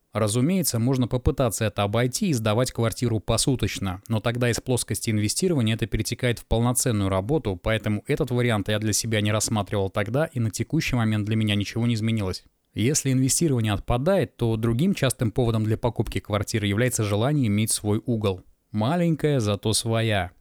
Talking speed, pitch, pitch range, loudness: 160 wpm, 115 Hz, 105-125 Hz, -24 LUFS